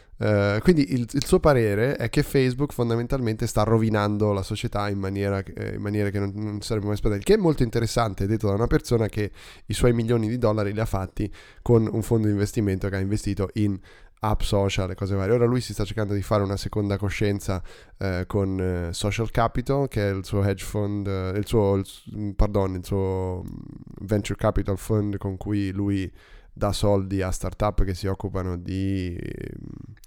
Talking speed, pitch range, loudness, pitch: 200 wpm, 100-115 Hz, -25 LUFS, 105 Hz